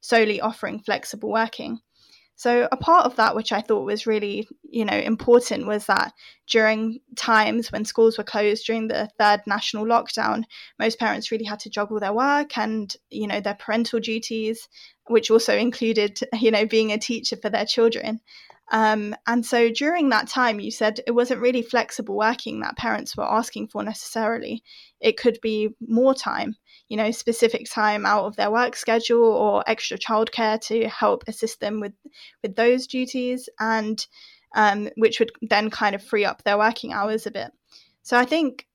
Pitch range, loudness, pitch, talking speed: 215-240 Hz, -22 LUFS, 225 Hz, 180 wpm